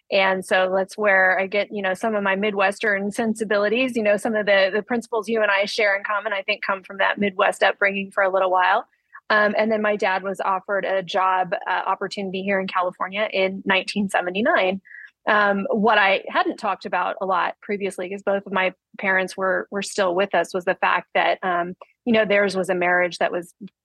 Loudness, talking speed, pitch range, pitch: -21 LUFS, 215 wpm, 190-210 Hz, 195 Hz